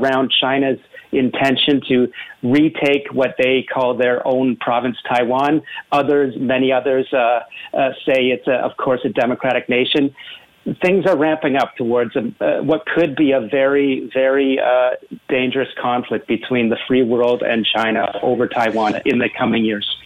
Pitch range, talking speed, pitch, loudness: 125-140 Hz, 160 wpm, 130 Hz, -17 LUFS